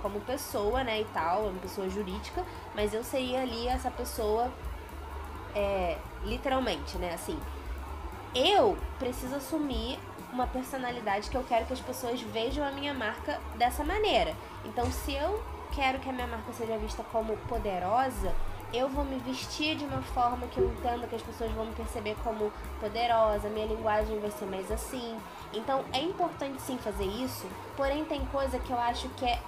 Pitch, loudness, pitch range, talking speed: 240 Hz, -32 LUFS, 215-265 Hz, 175 wpm